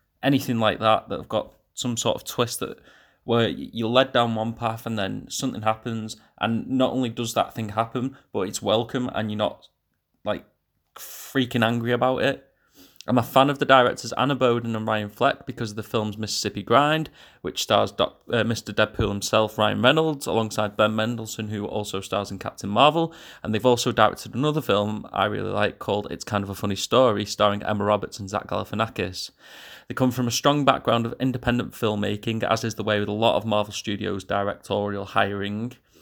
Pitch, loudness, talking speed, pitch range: 110 Hz, -24 LUFS, 195 wpm, 105-125 Hz